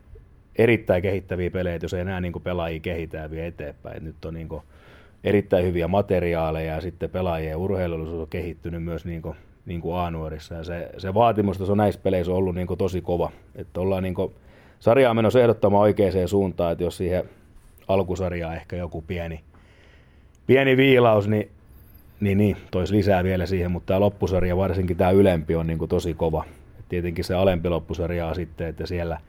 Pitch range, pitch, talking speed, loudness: 85-95 Hz, 90 Hz, 170 wpm, -23 LUFS